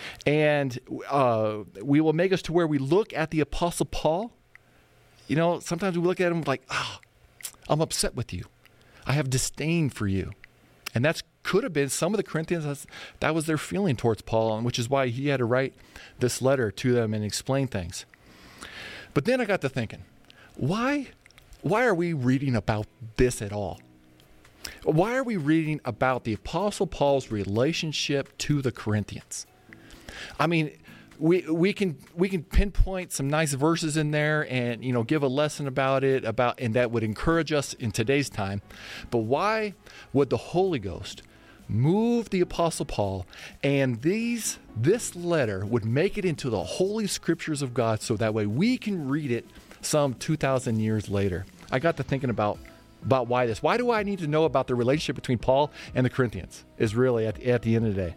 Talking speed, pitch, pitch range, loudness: 190 wpm, 135 Hz, 115-165 Hz, -26 LUFS